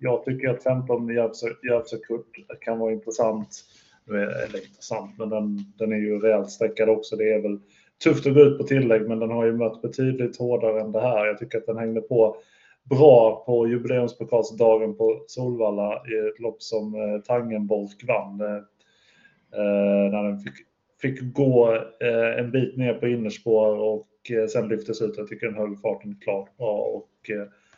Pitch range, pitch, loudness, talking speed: 105-120 Hz, 110 Hz, -24 LUFS, 180 wpm